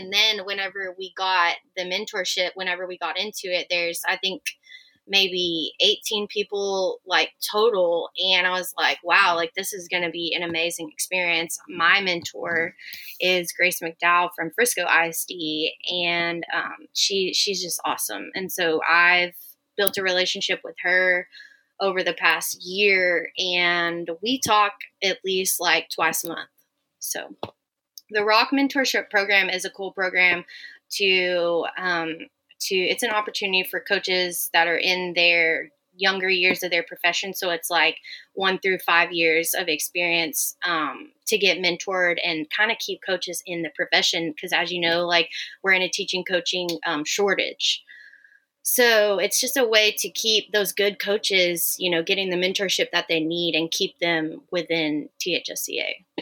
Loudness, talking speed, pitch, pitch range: -22 LUFS, 160 wpm, 185 Hz, 170-200 Hz